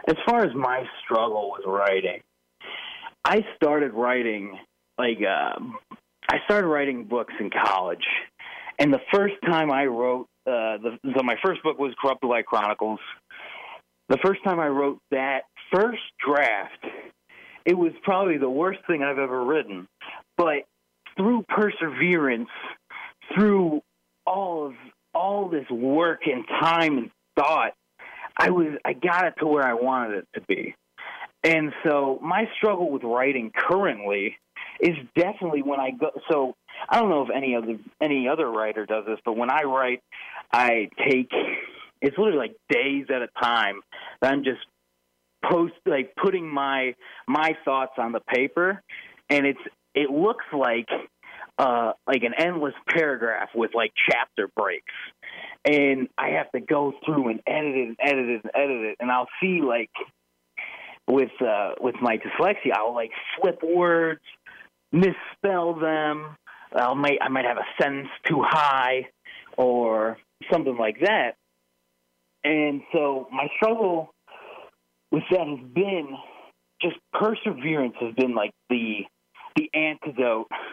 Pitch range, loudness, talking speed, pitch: 115-165 Hz, -24 LUFS, 145 wpm, 135 Hz